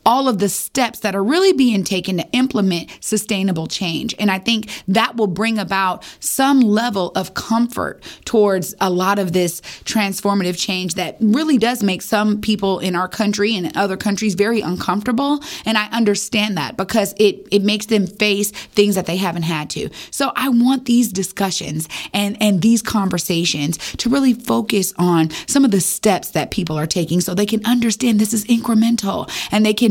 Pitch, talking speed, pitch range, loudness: 205 Hz, 185 wpm, 185-230 Hz, -18 LUFS